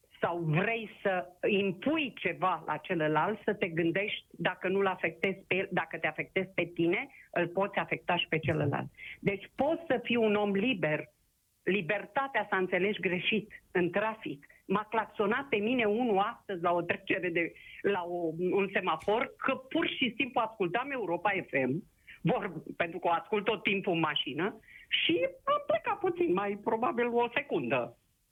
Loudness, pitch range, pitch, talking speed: -31 LUFS, 175-225 Hz, 195 Hz, 165 wpm